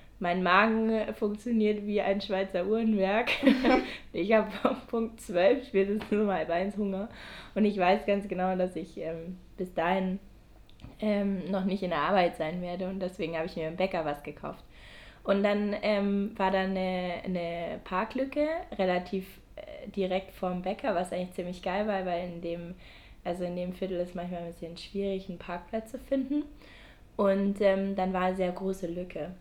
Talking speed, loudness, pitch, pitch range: 170 wpm, -30 LUFS, 190 Hz, 180-210 Hz